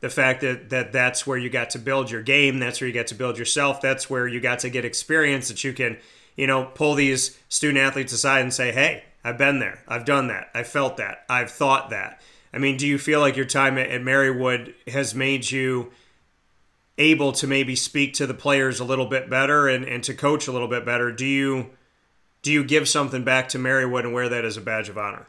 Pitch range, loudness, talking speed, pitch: 125-135 Hz, -22 LUFS, 235 wpm, 130 Hz